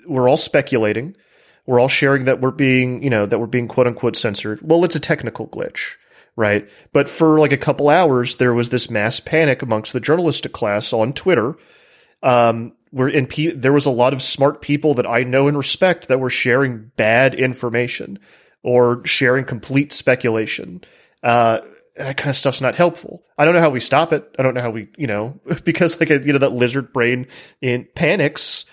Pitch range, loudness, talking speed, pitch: 120-145 Hz, -17 LUFS, 195 wpm, 130 Hz